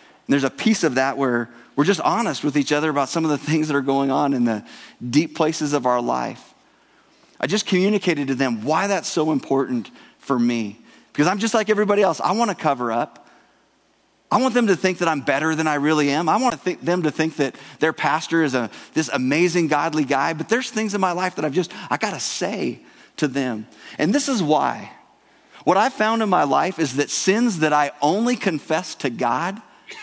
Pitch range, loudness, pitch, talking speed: 140-185 Hz, -21 LUFS, 155 Hz, 225 wpm